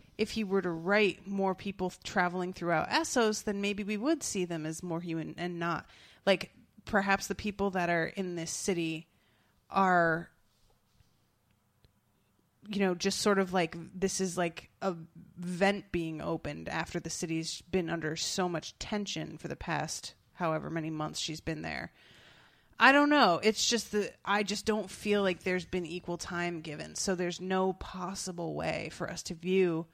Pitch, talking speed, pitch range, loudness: 180 Hz, 170 wpm, 165-195 Hz, -32 LUFS